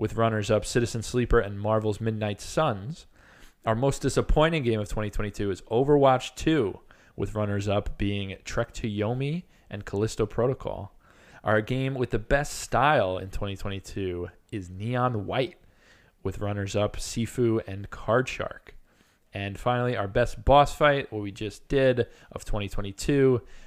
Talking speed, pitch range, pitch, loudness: 145 wpm, 100-125 Hz, 110 Hz, -27 LUFS